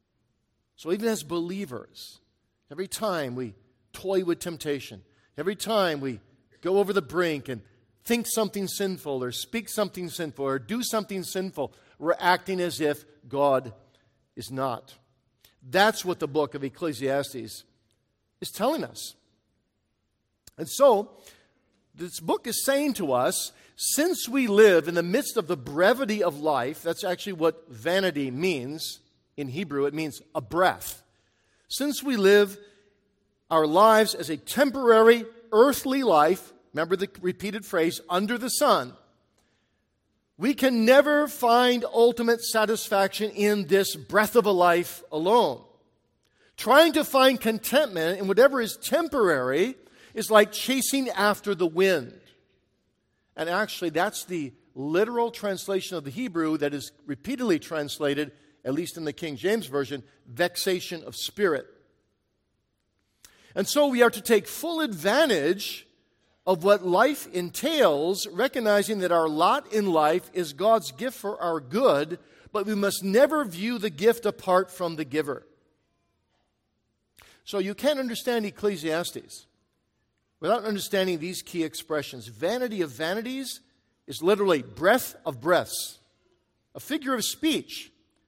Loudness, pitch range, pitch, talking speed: -25 LUFS, 150-220 Hz, 185 Hz, 135 wpm